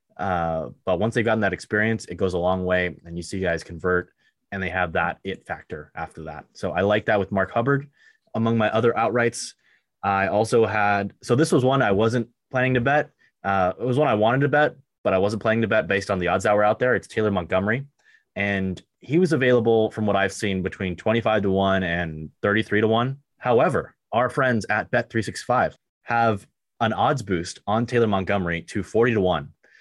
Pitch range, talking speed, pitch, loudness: 95-120 Hz, 210 wpm, 105 Hz, -23 LUFS